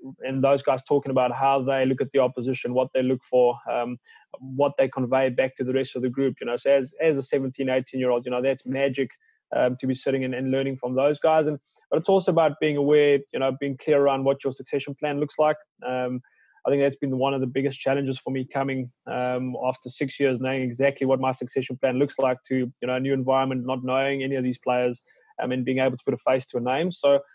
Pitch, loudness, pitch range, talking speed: 135 Hz, -24 LUFS, 130-140 Hz, 255 wpm